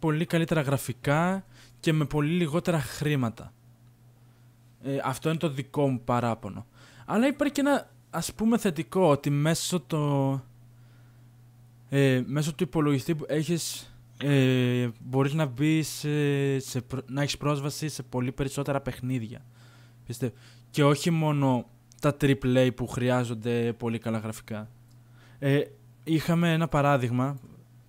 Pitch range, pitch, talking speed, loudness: 120-150 Hz, 135 Hz, 125 wpm, -27 LUFS